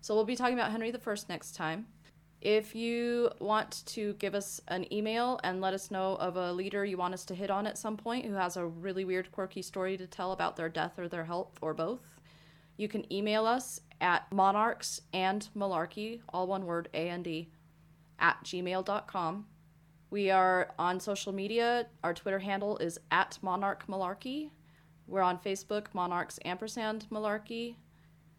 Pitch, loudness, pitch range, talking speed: 190 Hz, -34 LUFS, 175-215 Hz, 165 wpm